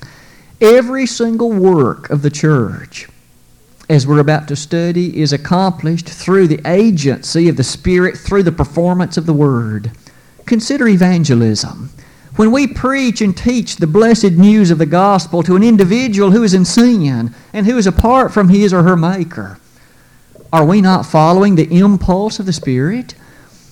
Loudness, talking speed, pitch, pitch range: -12 LUFS, 160 wpm, 175 Hz, 150-205 Hz